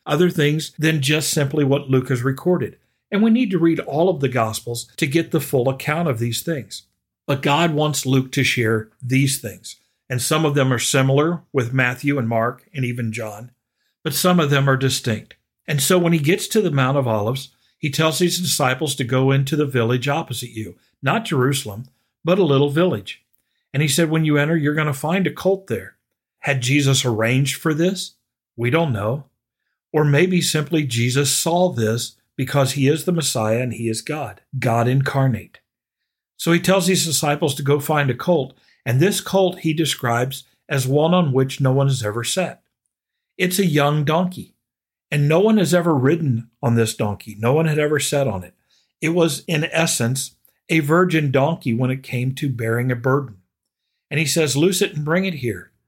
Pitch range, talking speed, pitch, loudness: 125-160 Hz, 200 wpm, 140 Hz, -19 LUFS